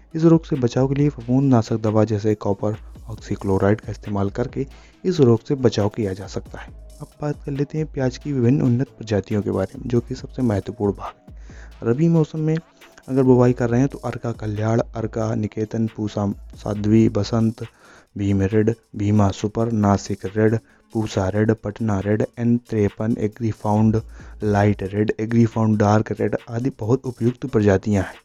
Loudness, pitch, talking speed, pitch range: -21 LUFS, 110 Hz, 170 wpm, 105-125 Hz